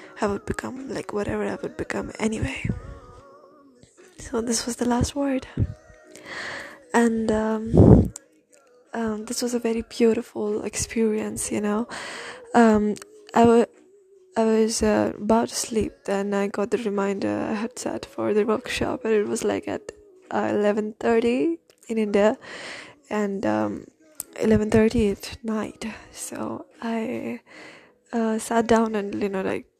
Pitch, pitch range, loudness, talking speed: 225 Hz, 210-240 Hz, -24 LUFS, 145 wpm